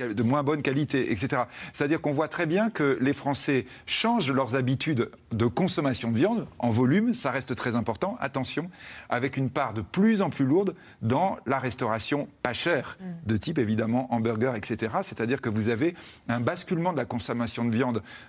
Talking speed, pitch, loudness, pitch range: 185 wpm, 130 Hz, -27 LUFS, 120-150 Hz